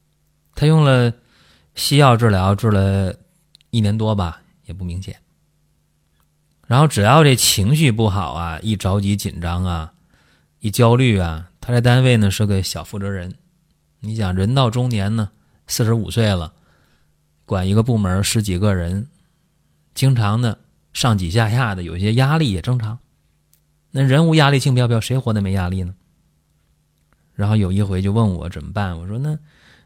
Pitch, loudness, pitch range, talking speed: 105 Hz, -18 LUFS, 90-130 Hz, 225 characters per minute